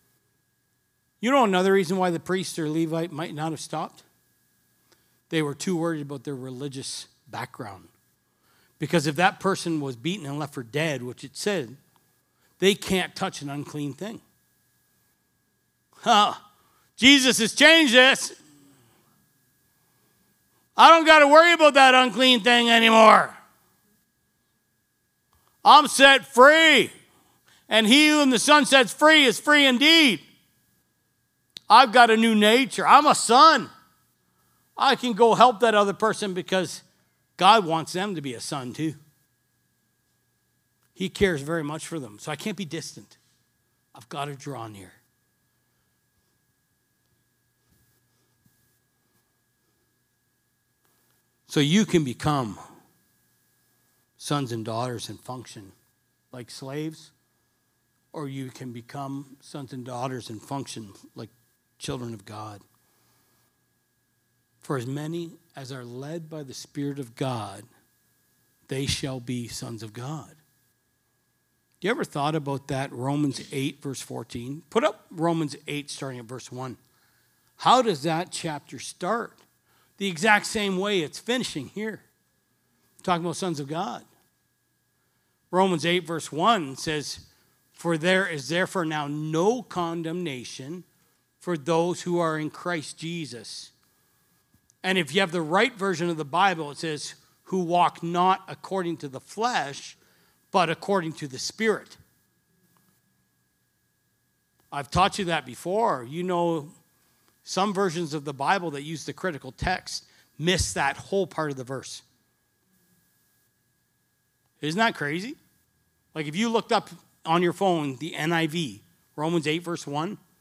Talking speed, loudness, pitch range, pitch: 135 wpm, -22 LUFS, 130-185 Hz, 155 Hz